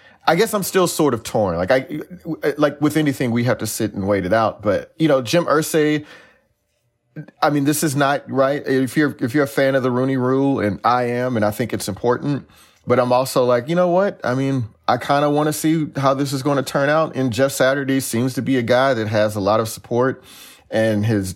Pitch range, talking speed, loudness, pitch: 120-150 Hz, 245 wpm, -19 LUFS, 135 Hz